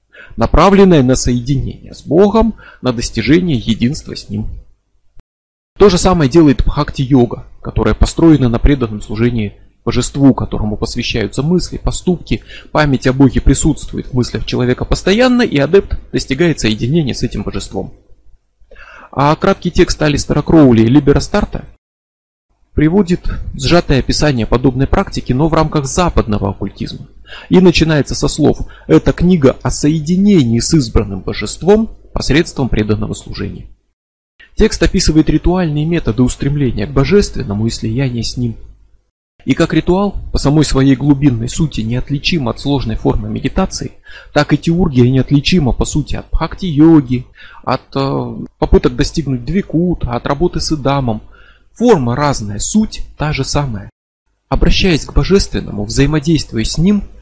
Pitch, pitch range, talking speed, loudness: 135 Hz, 115-160 Hz, 130 wpm, -13 LUFS